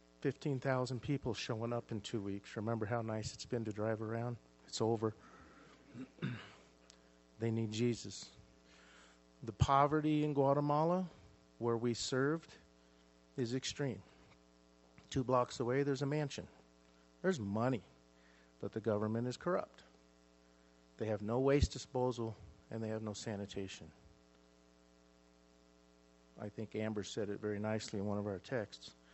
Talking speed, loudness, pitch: 130 wpm, -39 LUFS, 105 Hz